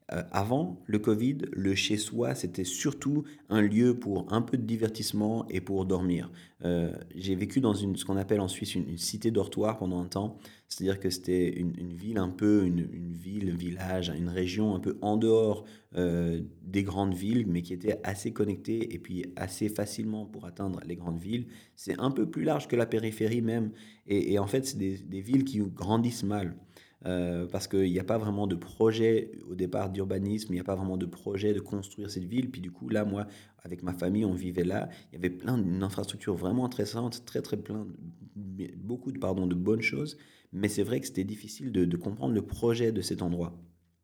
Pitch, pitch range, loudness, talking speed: 100 Hz, 90-110 Hz, -31 LUFS, 215 wpm